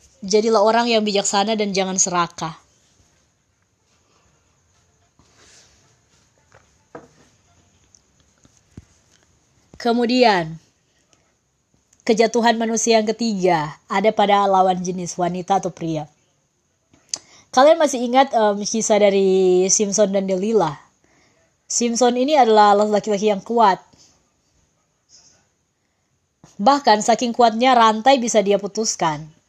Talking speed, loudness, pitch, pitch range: 85 wpm, -17 LUFS, 205 Hz, 180-230 Hz